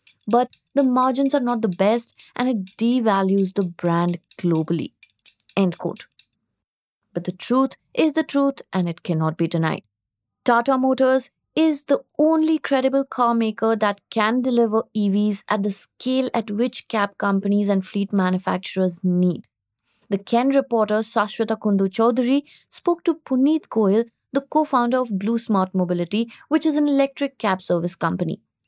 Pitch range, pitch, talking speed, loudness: 190-260 Hz, 220 Hz, 155 wpm, -21 LUFS